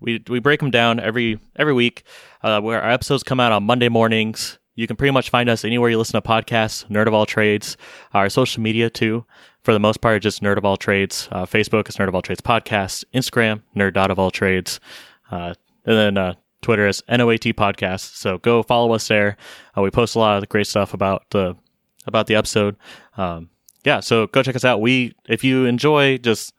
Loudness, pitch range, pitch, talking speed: -18 LUFS, 100-120 Hz, 110 Hz, 220 wpm